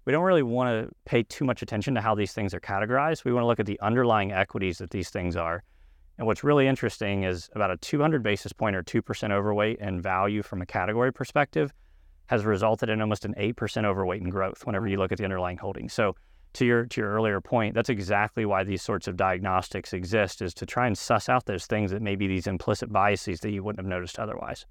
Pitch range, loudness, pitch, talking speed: 95-115 Hz, -27 LUFS, 105 Hz, 235 wpm